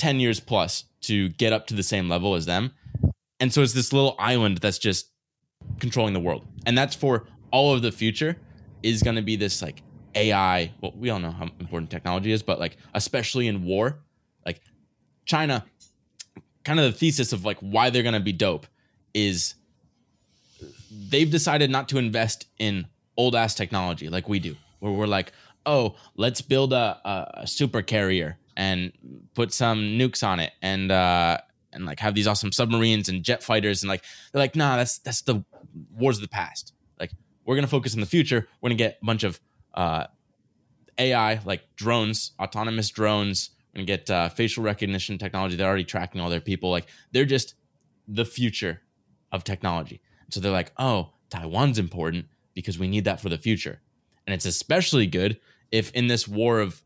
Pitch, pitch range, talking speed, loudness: 105 Hz, 95-120 Hz, 190 wpm, -25 LUFS